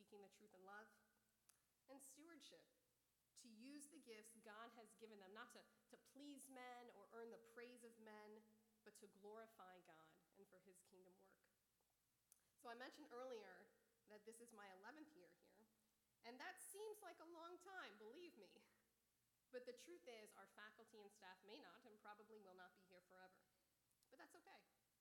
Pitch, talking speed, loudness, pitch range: 225 Hz, 180 wpm, -63 LUFS, 205-270 Hz